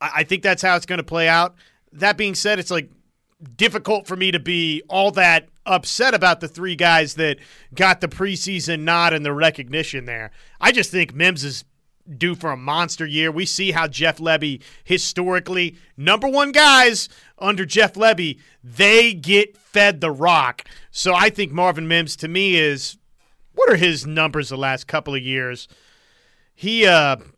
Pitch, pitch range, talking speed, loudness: 170 Hz, 155-190 Hz, 180 wpm, -17 LUFS